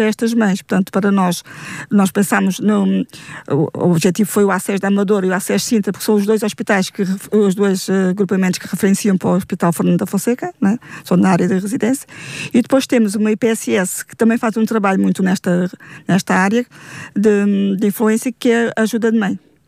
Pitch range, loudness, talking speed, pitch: 190-220 Hz, -16 LUFS, 200 wpm, 200 Hz